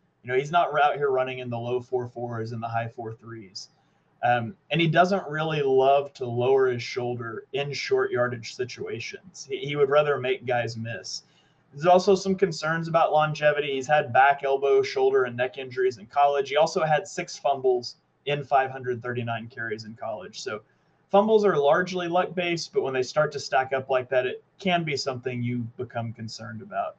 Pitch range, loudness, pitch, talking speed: 125-170 Hz, -25 LUFS, 140 Hz, 195 wpm